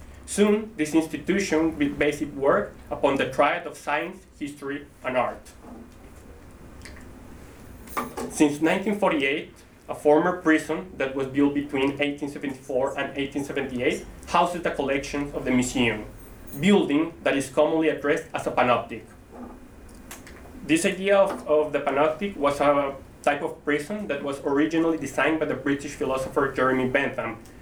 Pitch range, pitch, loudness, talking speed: 135-155 Hz, 145 Hz, -25 LUFS, 135 wpm